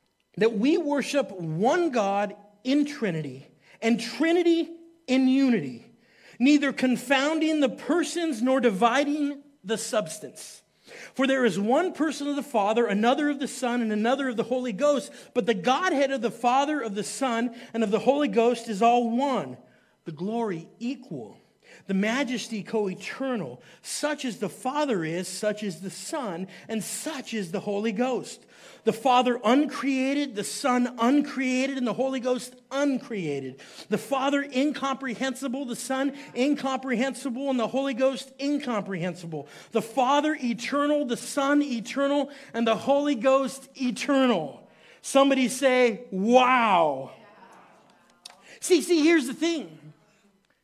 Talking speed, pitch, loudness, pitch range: 135 wpm, 255 Hz, -26 LUFS, 220-275 Hz